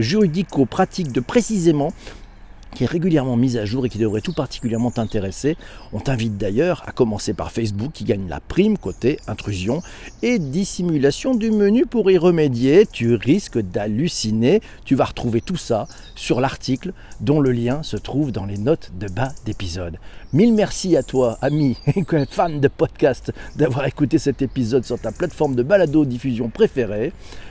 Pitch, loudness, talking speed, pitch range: 130 Hz, -20 LUFS, 170 wpm, 110-165 Hz